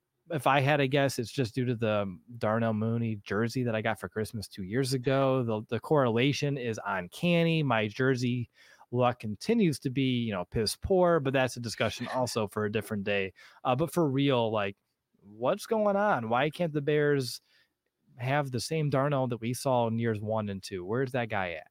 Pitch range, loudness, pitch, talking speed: 110-140 Hz, -29 LUFS, 125 Hz, 200 wpm